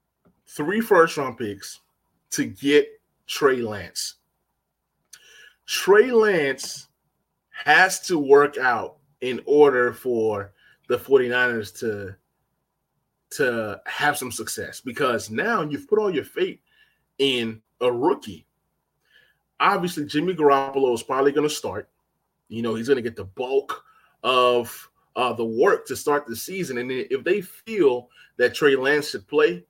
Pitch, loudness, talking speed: 145 Hz, -22 LUFS, 135 wpm